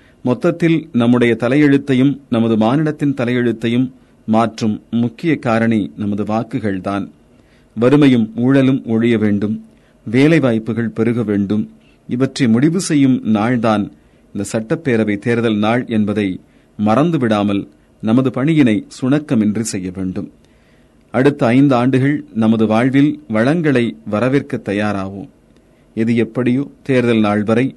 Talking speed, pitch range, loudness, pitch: 100 wpm, 105-130 Hz, -16 LUFS, 115 Hz